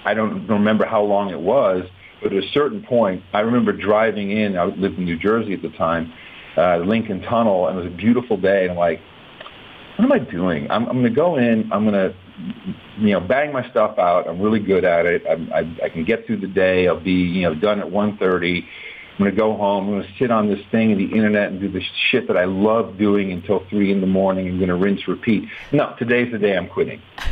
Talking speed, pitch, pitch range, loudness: 255 wpm, 100 Hz, 95-110 Hz, -19 LUFS